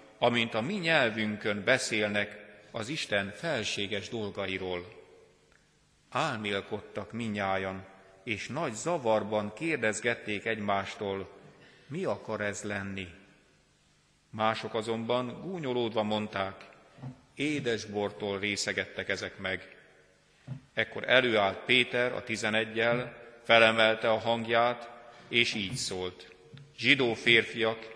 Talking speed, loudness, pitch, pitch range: 90 wpm, -30 LUFS, 110 Hz, 100-120 Hz